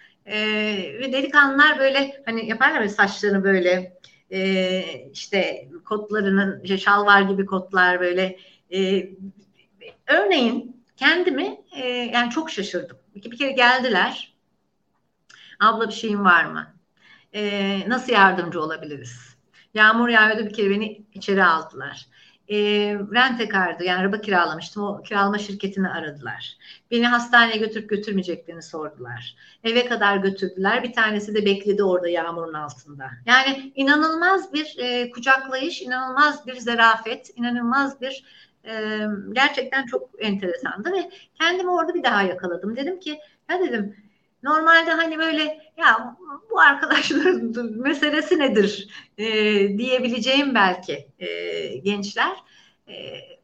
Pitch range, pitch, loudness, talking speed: 195-270 Hz, 220 Hz, -20 LUFS, 120 wpm